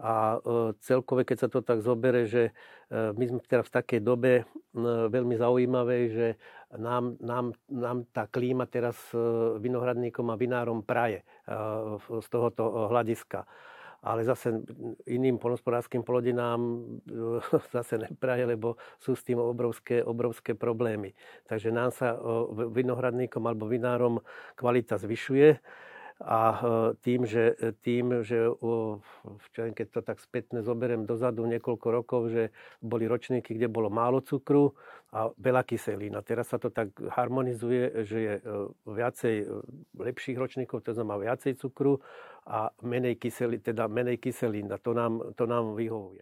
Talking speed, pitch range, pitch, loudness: 130 wpm, 115-125 Hz, 120 Hz, -30 LUFS